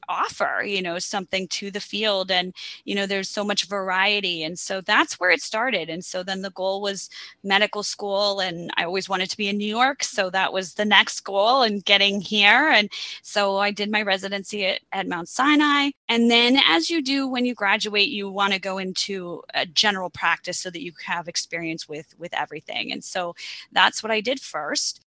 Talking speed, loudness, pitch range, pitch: 210 wpm, -22 LUFS, 185-210 Hz, 195 Hz